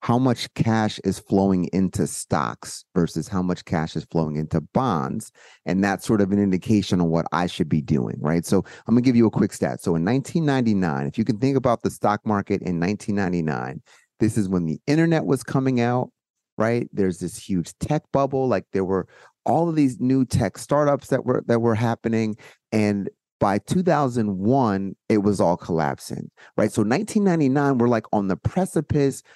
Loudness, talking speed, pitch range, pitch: -22 LUFS, 190 wpm, 95-130 Hz, 110 Hz